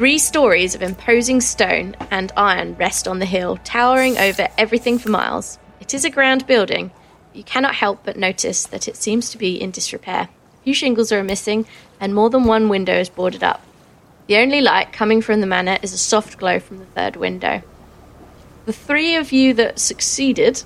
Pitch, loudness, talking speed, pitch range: 220 Hz, -17 LUFS, 195 wpm, 195-255 Hz